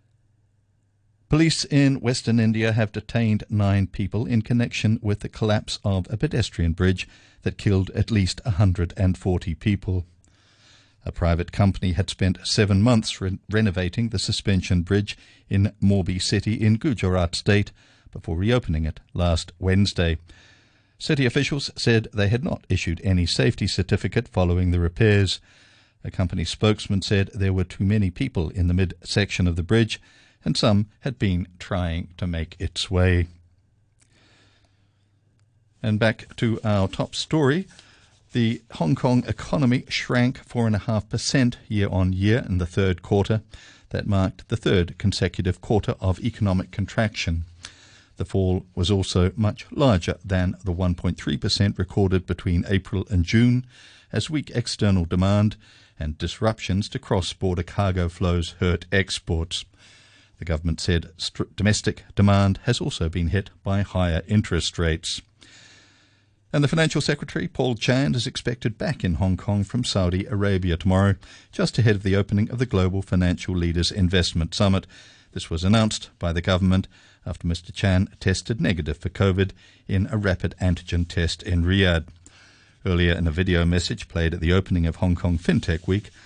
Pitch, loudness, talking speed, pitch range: 100 Hz, -23 LUFS, 150 wpm, 90-110 Hz